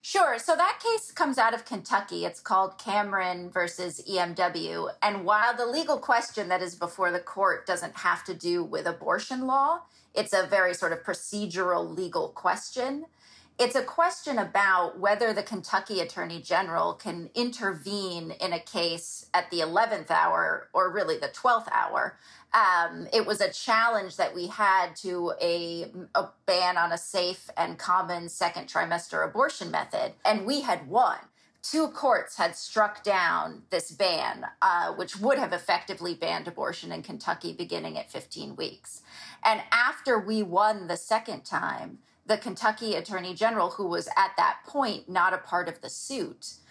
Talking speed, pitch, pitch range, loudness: 165 wpm, 200 Hz, 180-240 Hz, -28 LUFS